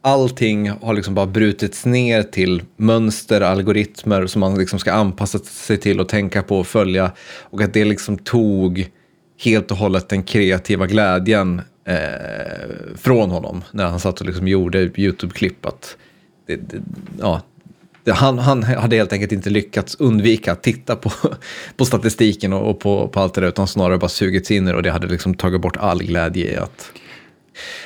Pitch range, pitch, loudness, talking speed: 95-110 Hz, 100 Hz, -18 LUFS, 170 wpm